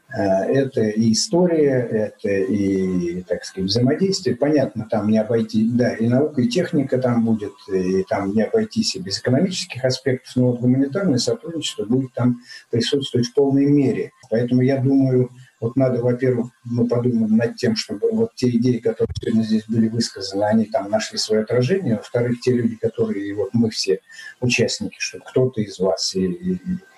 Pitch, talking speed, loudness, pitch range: 125 Hz, 165 wpm, -20 LUFS, 110-140 Hz